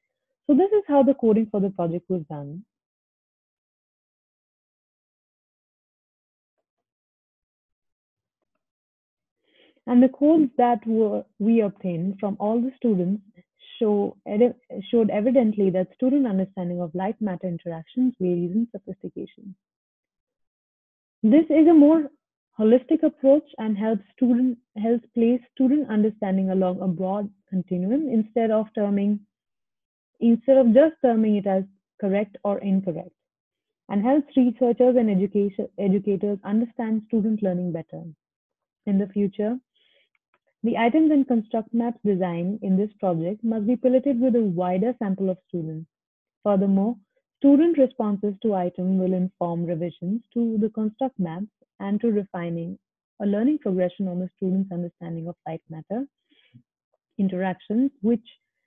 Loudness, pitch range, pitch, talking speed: -23 LUFS, 185-245 Hz, 210 Hz, 125 wpm